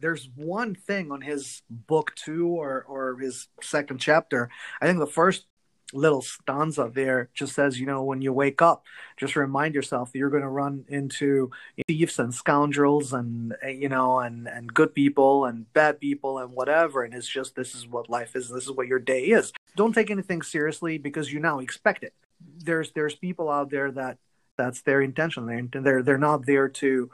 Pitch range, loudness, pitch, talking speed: 130-155 Hz, -25 LUFS, 140 Hz, 200 wpm